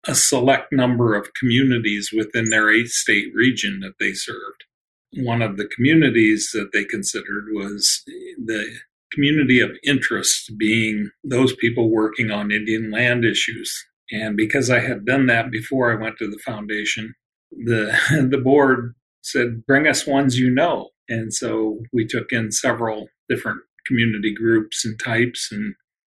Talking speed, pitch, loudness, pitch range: 150 wpm, 115 Hz, -19 LUFS, 110-130 Hz